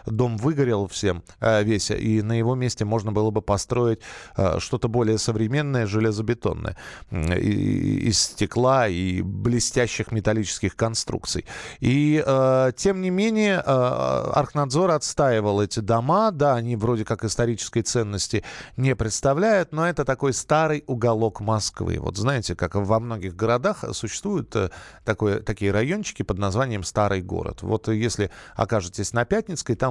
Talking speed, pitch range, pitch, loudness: 135 wpm, 105-130 Hz, 115 Hz, -23 LUFS